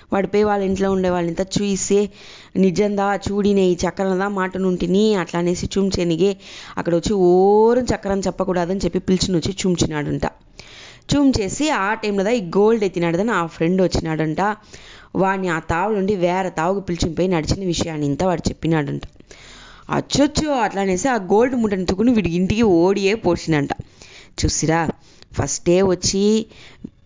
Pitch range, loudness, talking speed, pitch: 175-205 Hz, -19 LUFS, 130 wpm, 190 Hz